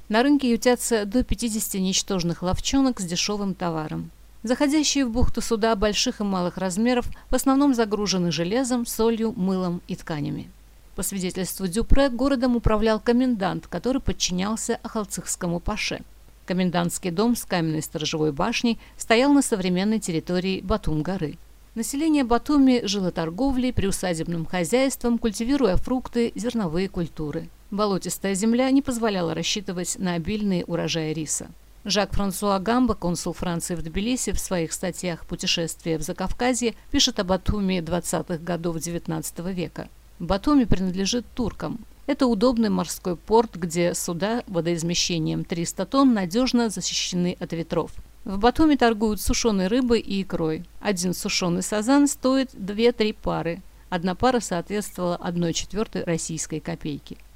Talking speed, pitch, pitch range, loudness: 130 wpm, 195 Hz, 175-235 Hz, -24 LUFS